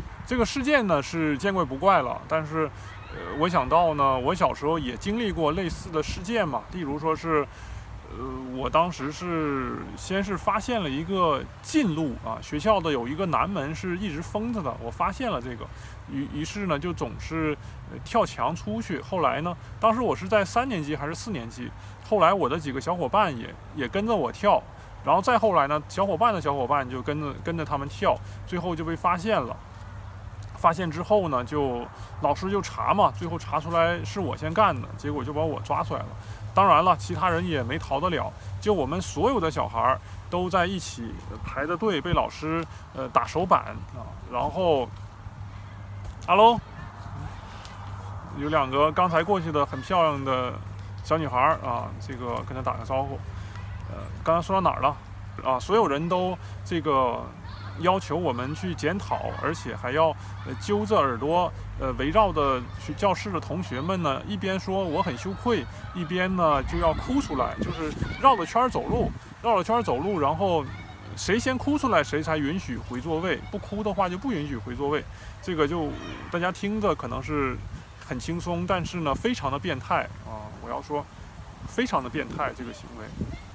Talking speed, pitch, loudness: 265 characters per minute, 140 Hz, -26 LUFS